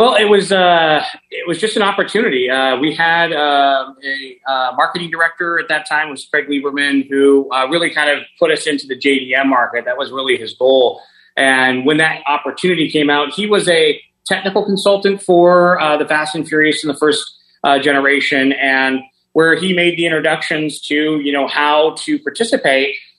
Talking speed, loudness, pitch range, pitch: 190 wpm, -14 LUFS, 140-175 Hz, 150 Hz